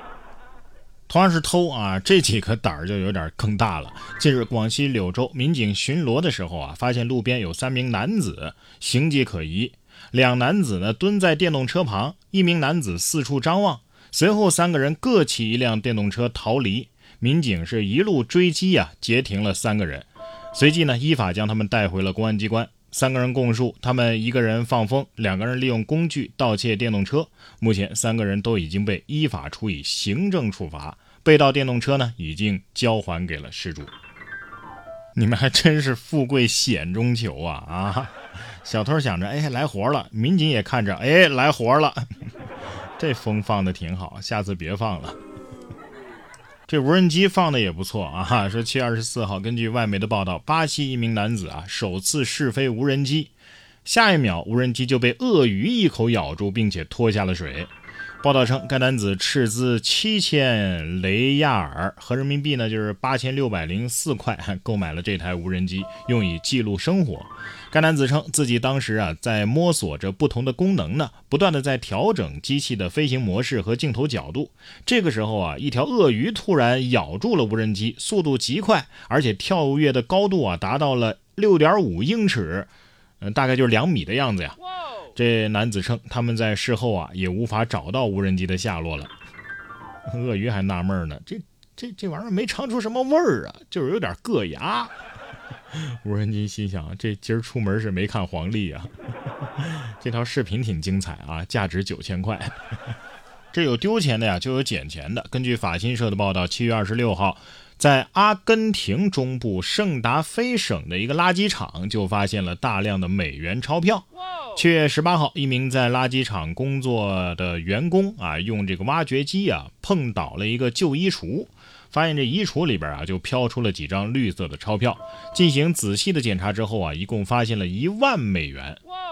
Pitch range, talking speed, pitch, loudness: 100-145 Hz, 270 characters per minute, 120 Hz, -22 LUFS